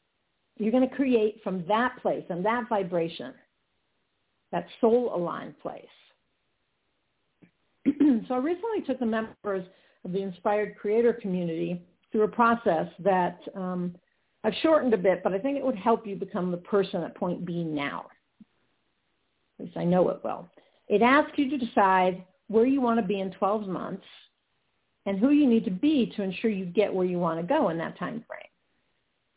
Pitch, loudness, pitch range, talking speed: 210 Hz, -27 LUFS, 185-240 Hz, 175 wpm